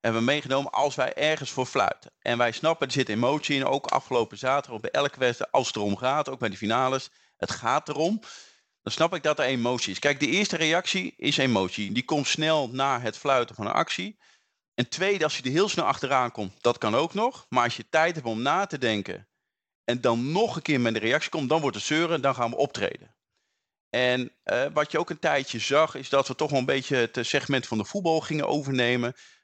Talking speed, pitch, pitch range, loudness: 240 wpm, 135 Hz, 120-155 Hz, -26 LUFS